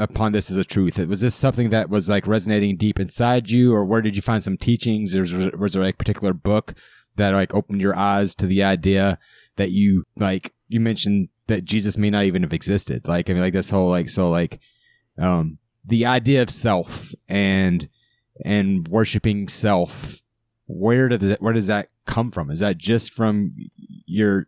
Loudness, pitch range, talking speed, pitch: -21 LUFS, 95-115 Hz, 195 wpm, 100 Hz